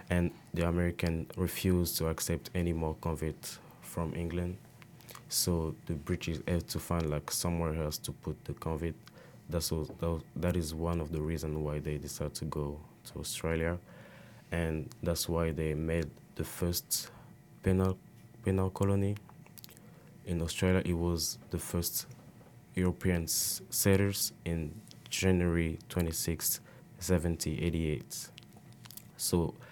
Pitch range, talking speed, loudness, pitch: 80-90 Hz, 125 wpm, -34 LUFS, 85 Hz